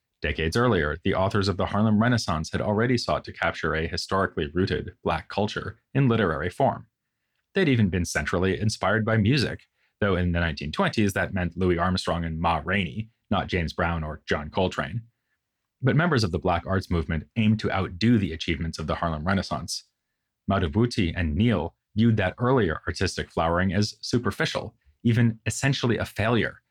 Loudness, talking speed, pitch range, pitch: -25 LUFS, 170 wpm, 85-110 Hz, 95 Hz